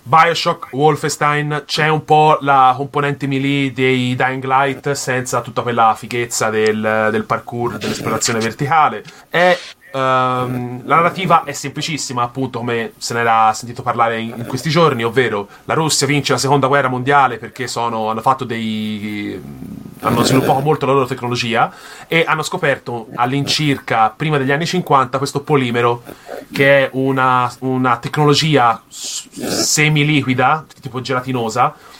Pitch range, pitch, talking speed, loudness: 120-145 Hz, 130 Hz, 135 wpm, -16 LUFS